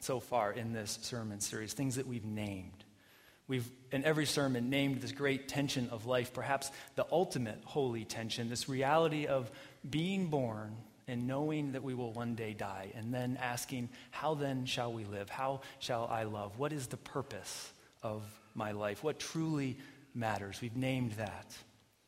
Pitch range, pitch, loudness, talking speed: 110-135 Hz, 125 Hz, -38 LUFS, 170 wpm